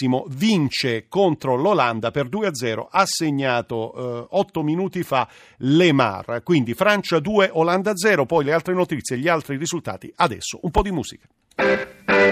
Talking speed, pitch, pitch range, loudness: 135 wpm, 150 Hz, 120-175 Hz, -21 LUFS